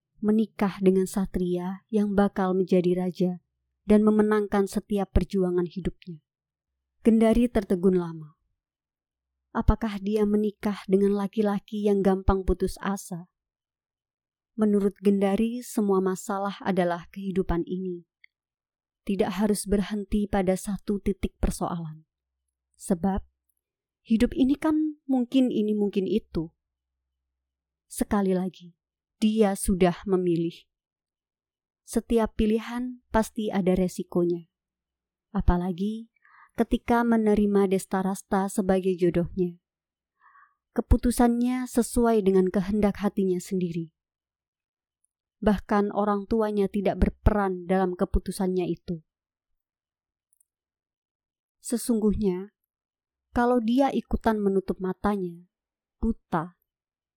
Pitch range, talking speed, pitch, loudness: 170-210 Hz, 85 wpm, 195 Hz, -26 LUFS